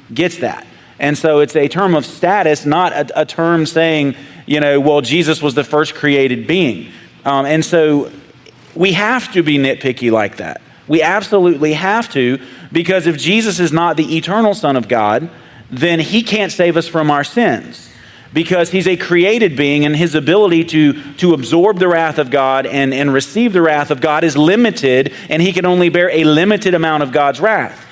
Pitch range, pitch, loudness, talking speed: 145-175 Hz, 155 Hz, -13 LUFS, 195 wpm